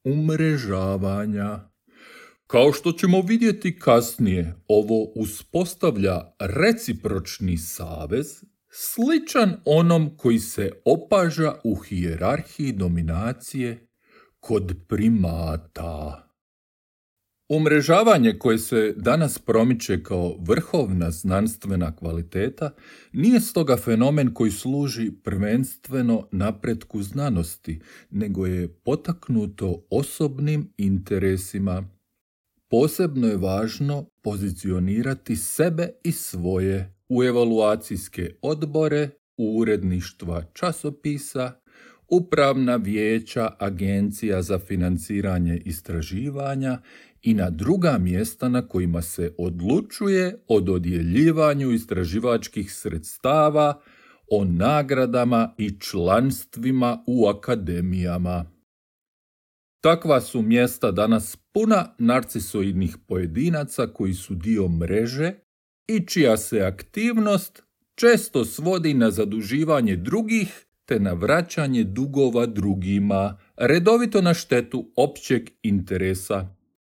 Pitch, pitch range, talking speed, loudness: 115 Hz, 95-150 Hz, 85 wpm, -23 LUFS